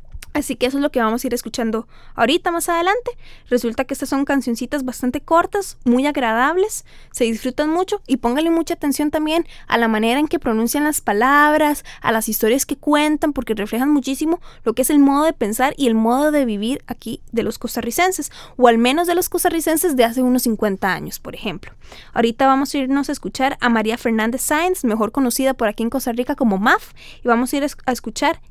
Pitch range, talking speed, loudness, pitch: 235-300 Hz, 210 wpm, -18 LUFS, 265 Hz